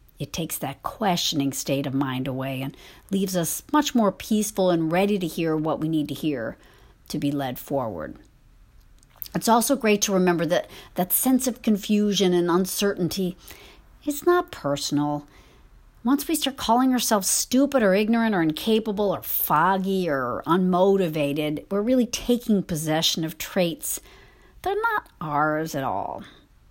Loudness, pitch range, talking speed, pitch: -24 LUFS, 155-220 Hz, 155 wpm, 185 Hz